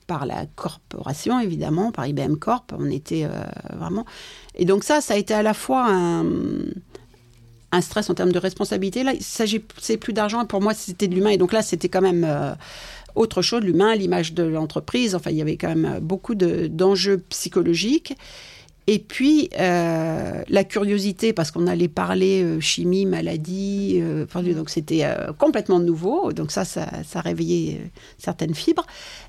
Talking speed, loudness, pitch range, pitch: 180 wpm, -22 LUFS, 170-215 Hz, 185 Hz